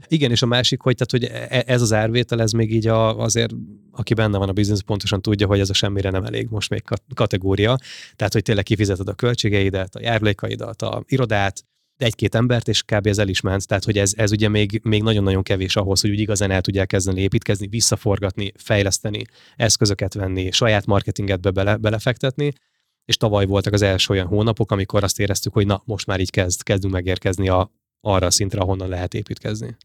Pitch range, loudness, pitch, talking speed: 100-115 Hz, -20 LUFS, 105 Hz, 200 wpm